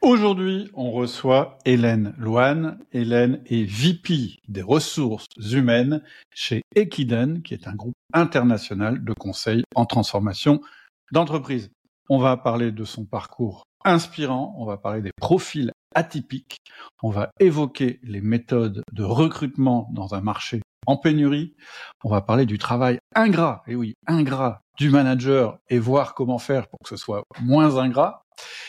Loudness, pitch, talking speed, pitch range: -22 LUFS, 125 Hz, 145 wpm, 115-145 Hz